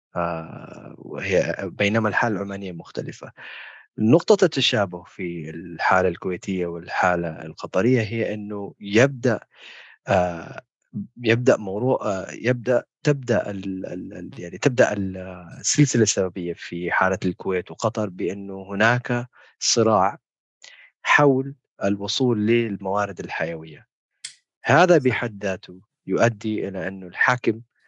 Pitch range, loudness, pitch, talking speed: 90-120 Hz, -22 LUFS, 100 Hz, 85 wpm